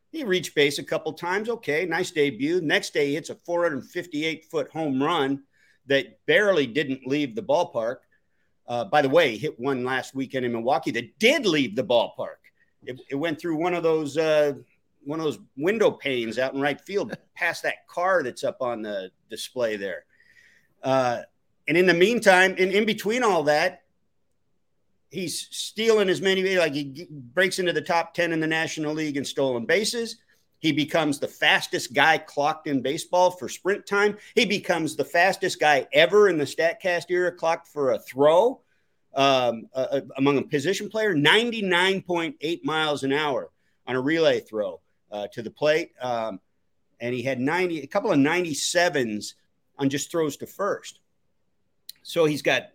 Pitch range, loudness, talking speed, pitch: 140-185 Hz, -24 LUFS, 175 wpm, 160 Hz